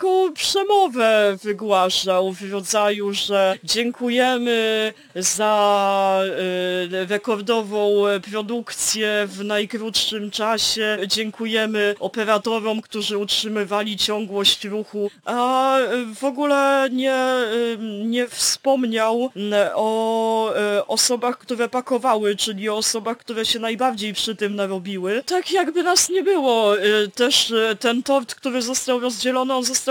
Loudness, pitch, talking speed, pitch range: -20 LUFS, 220 Hz, 100 wpm, 205-245 Hz